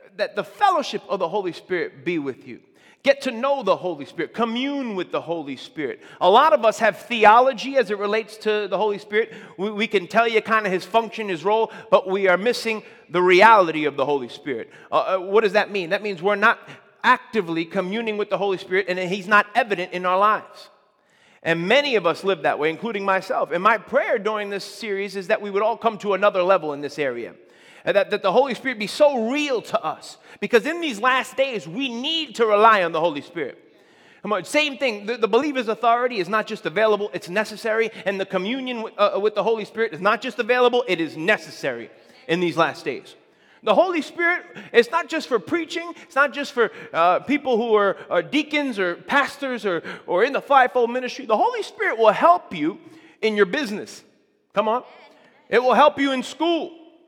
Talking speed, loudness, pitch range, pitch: 215 wpm, -21 LUFS, 200-265 Hz, 220 Hz